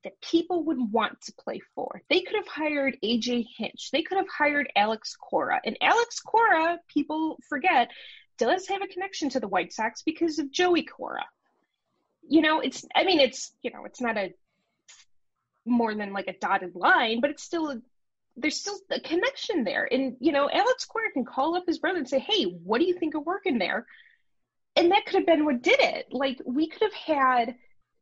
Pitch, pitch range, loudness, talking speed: 300 Hz, 245-360 Hz, -26 LUFS, 200 wpm